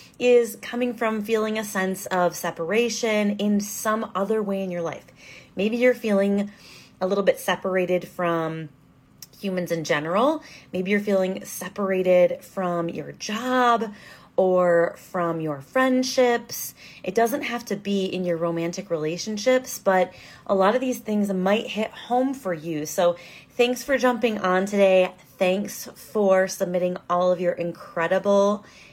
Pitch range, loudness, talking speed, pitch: 180-220 Hz, -24 LUFS, 145 wpm, 195 Hz